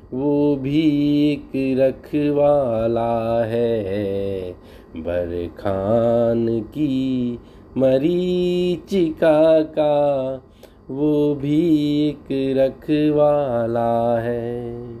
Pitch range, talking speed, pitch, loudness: 115-150 Hz, 65 wpm, 130 Hz, -20 LUFS